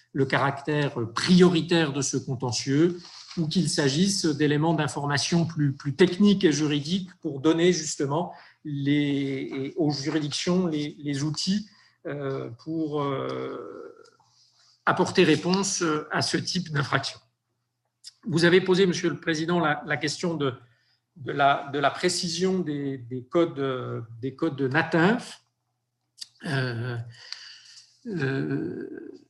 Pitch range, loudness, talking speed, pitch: 140-180 Hz, -25 LUFS, 115 wpm, 150 Hz